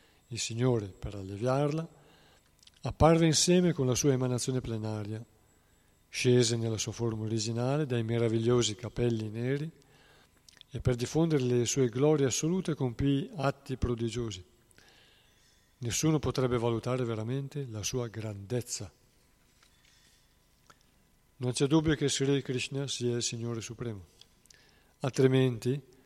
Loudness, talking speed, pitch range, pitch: -30 LUFS, 110 wpm, 115-140 Hz, 125 Hz